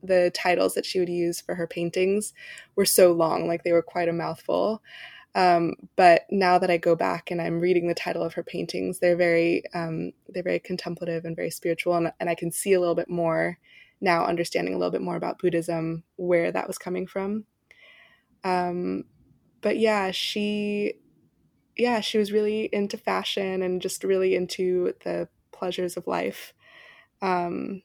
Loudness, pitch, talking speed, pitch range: -25 LUFS, 180 Hz, 180 wpm, 170-190 Hz